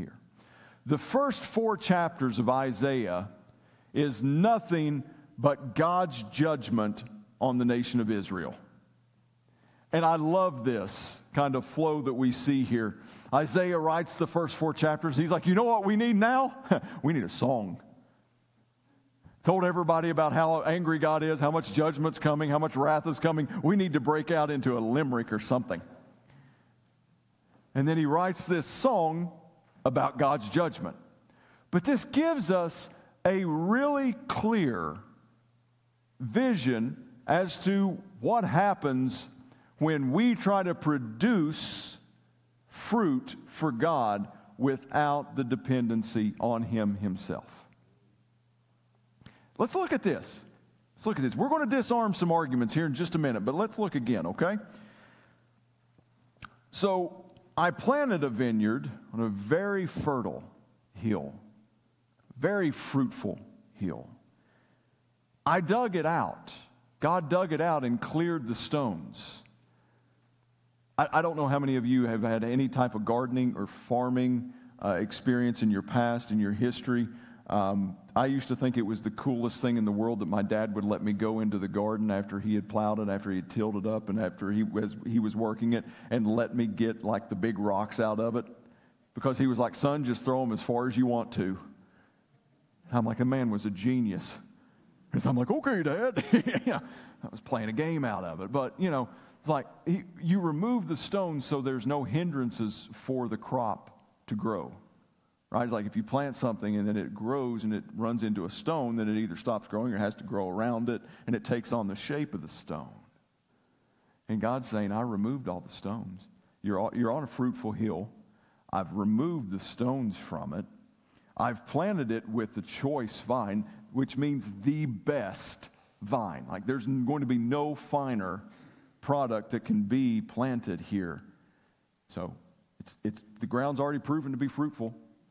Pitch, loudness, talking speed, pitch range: 130 Hz, -30 LUFS, 170 wpm, 115-160 Hz